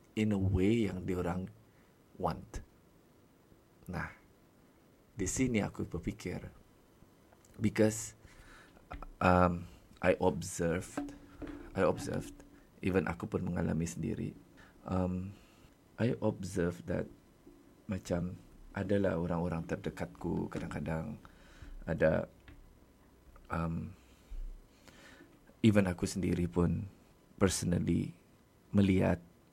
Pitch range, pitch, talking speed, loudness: 85-100 Hz, 90 Hz, 80 wpm, -34 LUFS